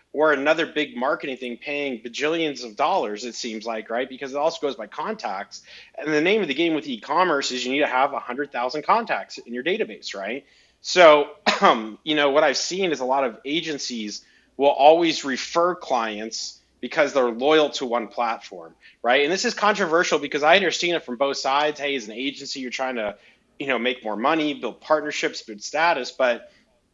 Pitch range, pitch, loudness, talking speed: 120-155 Hz, 140 Hz, -22 LUFS, 200 wpm